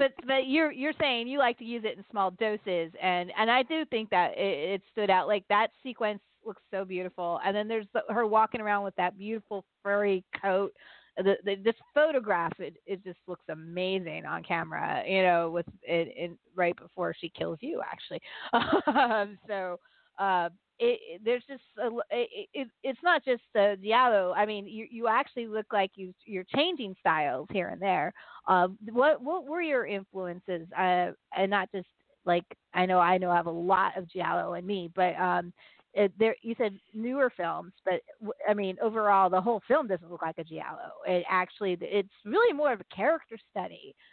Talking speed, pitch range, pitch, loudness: 195 wpm, 185-235 Hz, 200 Hz, -29 LUFS